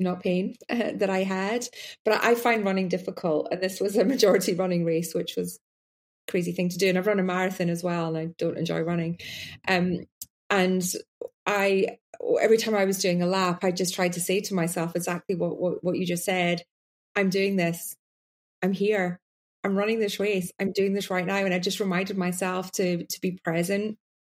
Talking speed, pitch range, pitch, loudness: 210 wpm, 175-200 Hz, 185 Hz, -26 LUFS